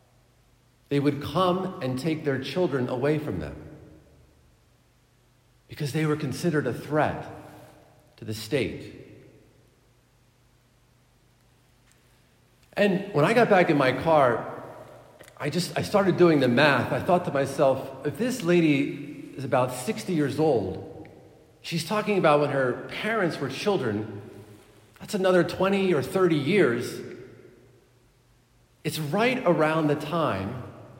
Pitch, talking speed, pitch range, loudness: 140 Hz, 125 wpm, 120-165 Hz, -25 LUFS